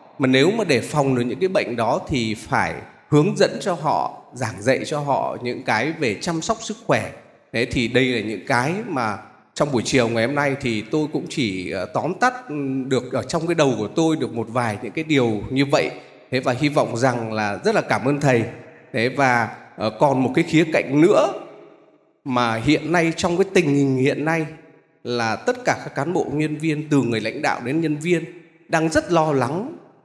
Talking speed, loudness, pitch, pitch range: 215 wpm, -21 LUFS, 140 Hz, 120-160 Hz